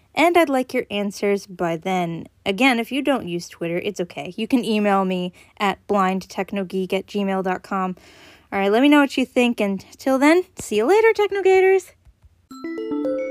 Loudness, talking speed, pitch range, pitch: -20 LUFS, 170 wpm, 190-265 Hz, 205 Hz